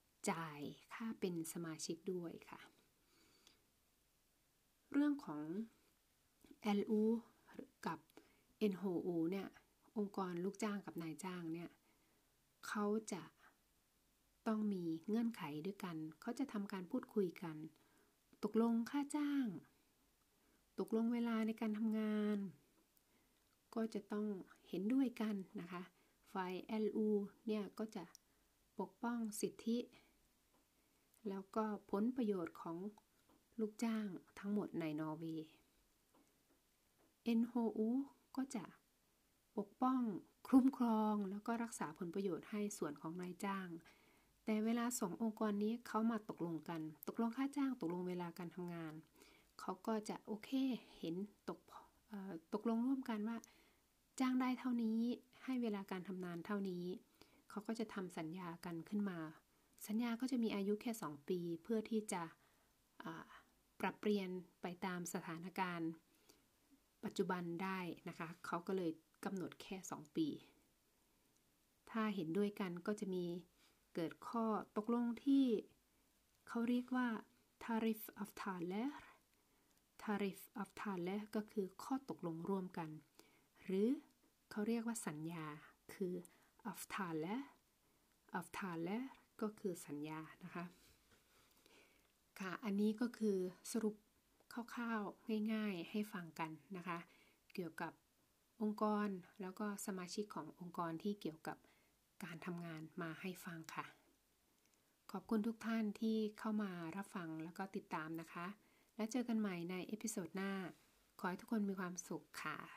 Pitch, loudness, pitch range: 205 Hz, -44 LUFS, 180-225 Hz